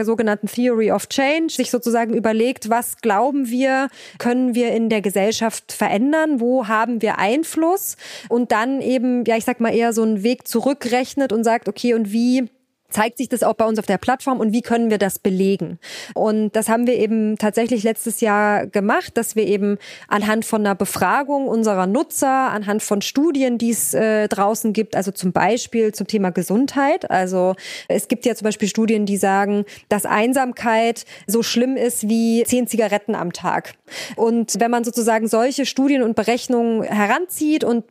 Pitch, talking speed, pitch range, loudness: 230 Hz, 180 wpm, 215-245 Hz, -19 LUFS